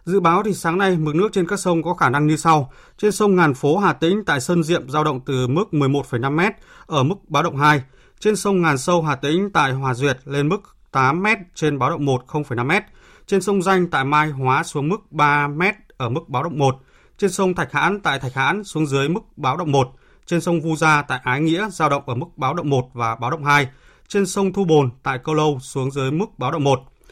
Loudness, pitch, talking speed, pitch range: -19 LUFS, 155 Hz, 250 wpm, 135-180 Hz